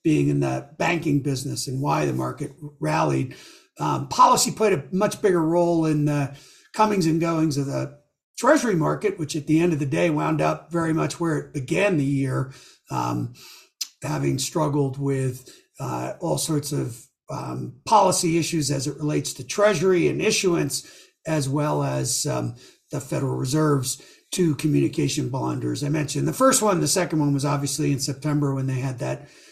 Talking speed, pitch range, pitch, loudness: 175 wpm, 130-165 Hz, 145 Hz, -23 LUFS